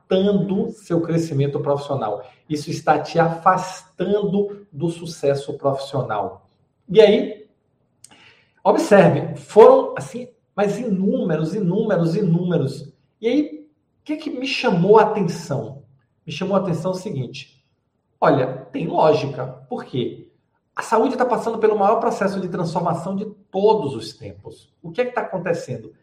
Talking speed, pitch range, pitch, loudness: 135 wpm, 145-215 Hz, 185 Hz, -20 LUFS